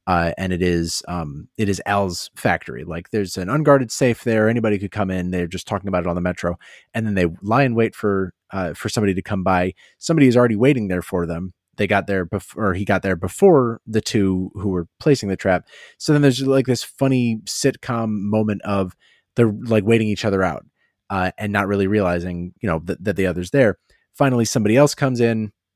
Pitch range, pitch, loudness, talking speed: 90-115 Hz, 100 Hz, -20 LUFS, 220 wpm